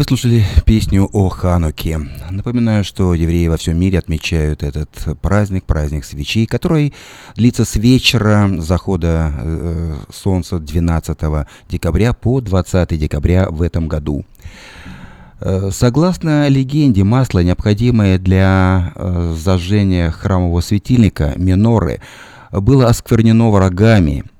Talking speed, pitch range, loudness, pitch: 105 wpm, 85-110 Hz, -15 LUFS, 95 Hz